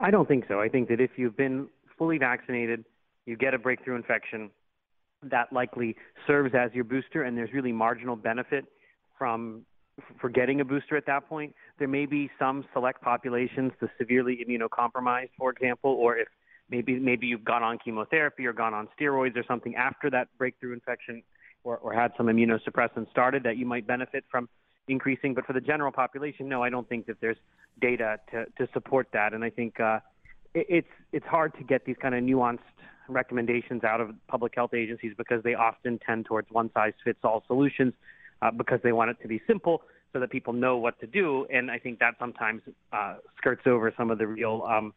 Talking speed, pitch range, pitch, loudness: 200 wpm, 115-130 Hz, 125 Hz, -28 LUFS